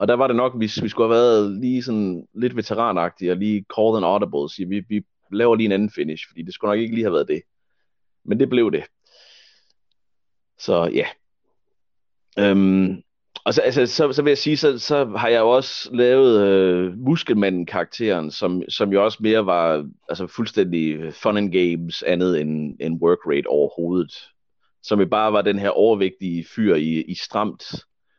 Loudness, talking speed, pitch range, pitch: -20 LUFS, 190 wpm, 90-115 Hz, 100 Hz